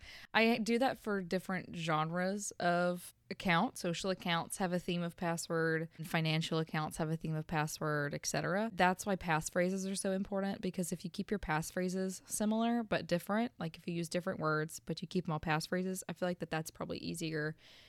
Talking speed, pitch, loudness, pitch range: 190 wpm, 180 Hz, -36 LUFS, 160-190 Hz